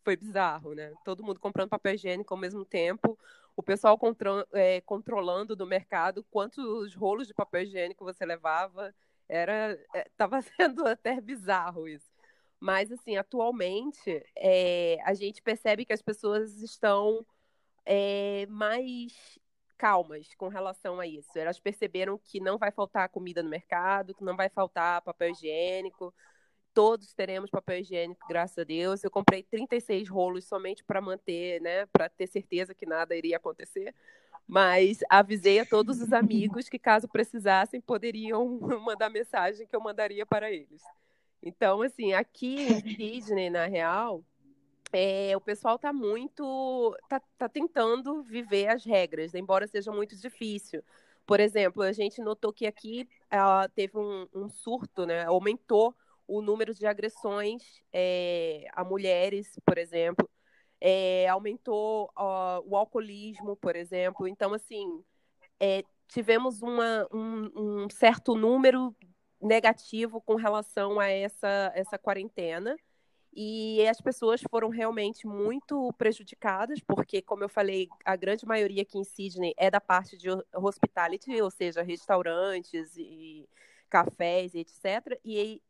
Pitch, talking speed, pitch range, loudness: 205 Hz, 140 wpm, 185-225 Hz, -29 LUFS